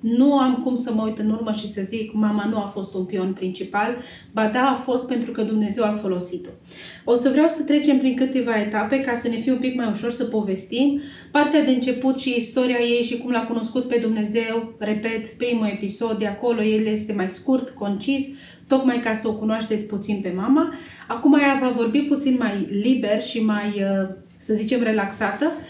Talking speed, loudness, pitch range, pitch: 205 wpm, -22 LUFS, 215-255 Hz, 230 Hz